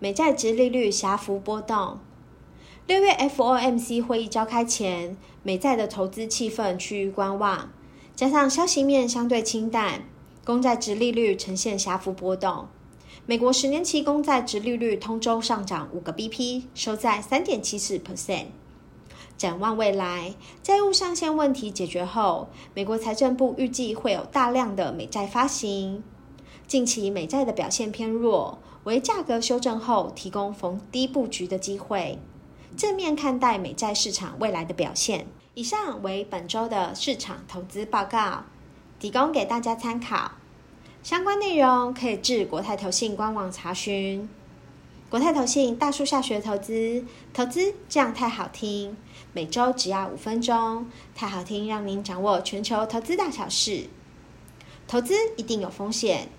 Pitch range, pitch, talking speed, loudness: 200-255 Hz, 225 Hz, 240 characters per minute, -25 LUFS